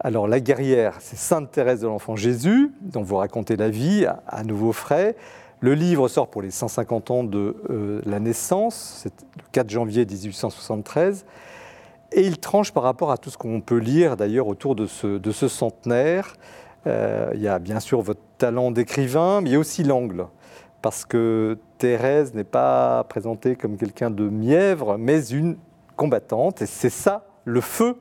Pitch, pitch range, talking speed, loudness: 120 Hz, 110-150 Hz, 180 wpm, -22 LUFS